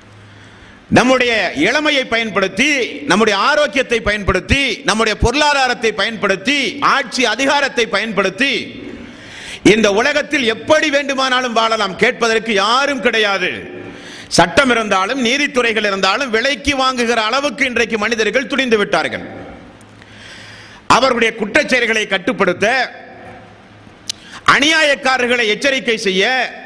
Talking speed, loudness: 85 wpm, -14 LUFS